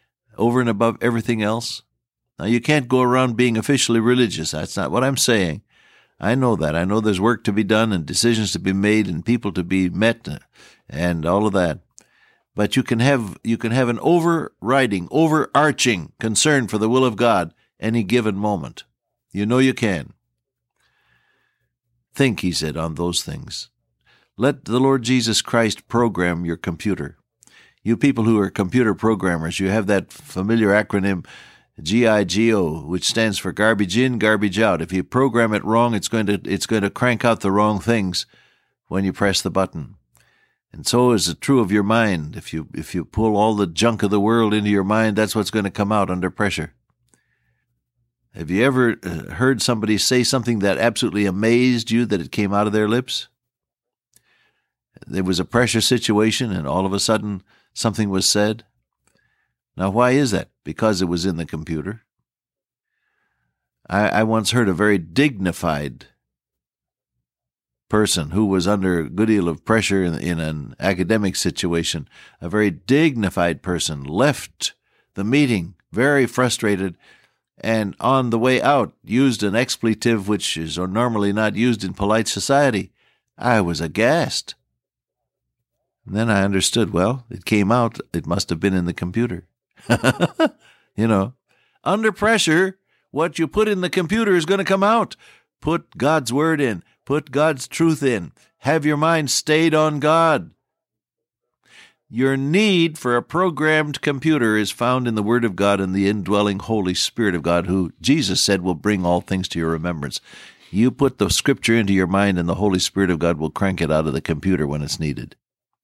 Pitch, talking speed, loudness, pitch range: 110 Hz, 175 wpm, -19 LUFS, 95-120 Hz